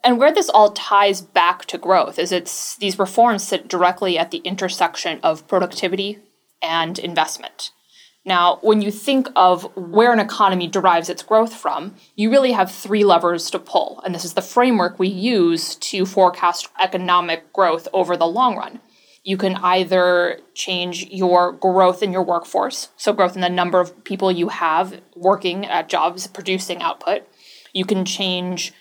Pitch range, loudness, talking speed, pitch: 180-200 Hz, -18 LUFS, 170 wpm, 185 Hz